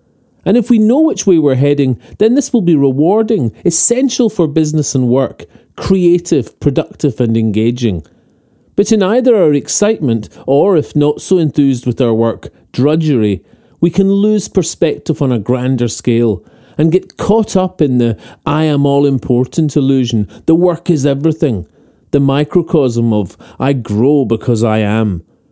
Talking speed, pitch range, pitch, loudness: 160 wpm, 120-180 Hz, 145 Hz, -12 LUFS